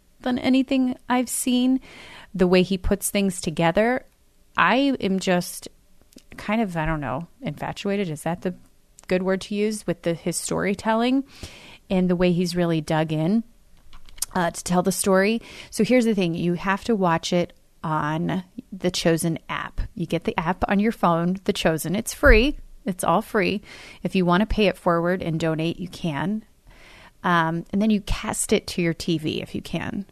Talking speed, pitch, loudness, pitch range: 185 wpm, 185 Hz, -23 LUFS, 170-215 Hz